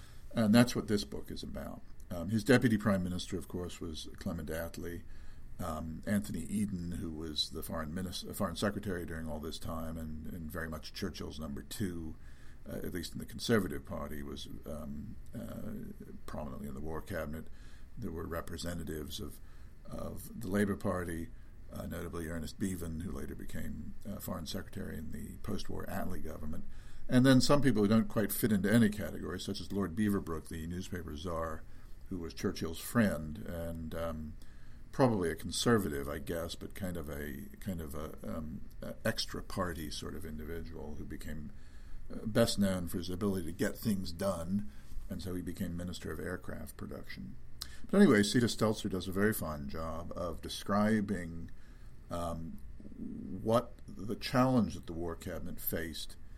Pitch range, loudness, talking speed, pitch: 80-100 Hz, -36 LUFS, 170 wpm, 85 Hz